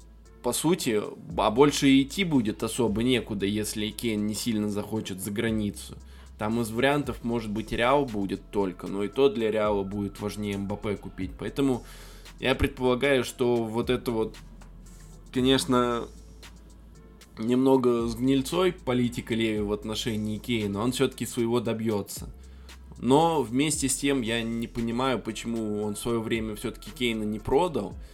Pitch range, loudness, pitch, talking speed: 105-125 Hz, -27 LUFS, 115 Hz, 145 wpm